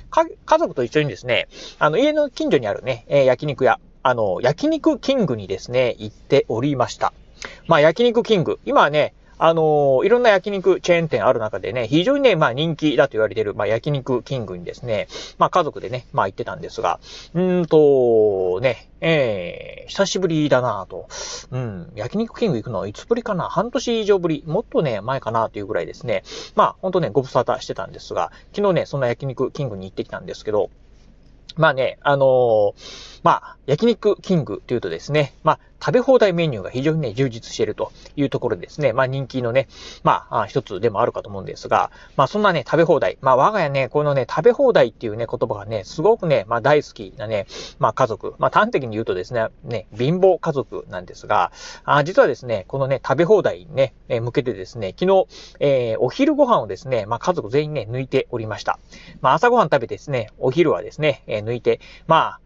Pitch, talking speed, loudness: 155 Hz, 405 characters per minute, -20 LUFS